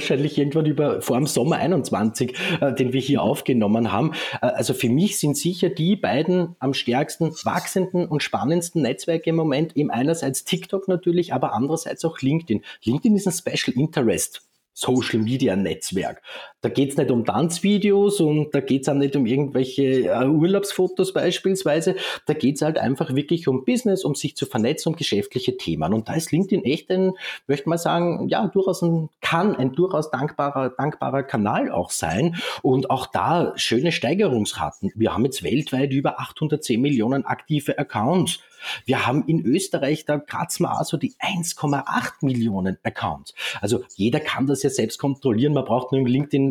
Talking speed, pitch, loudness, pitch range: 170 wpm, 150 Hz, -22 LUFS, 135-175 Hz